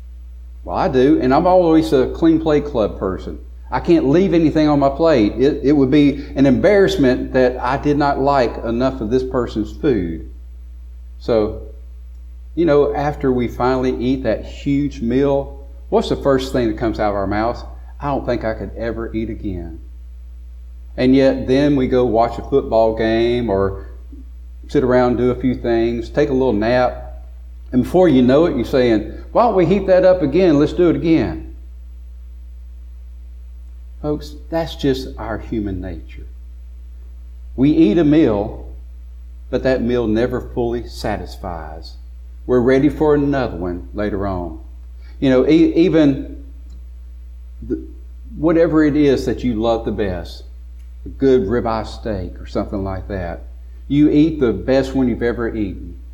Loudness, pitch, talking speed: -17 LUFS, 110 Hz, 160 wpm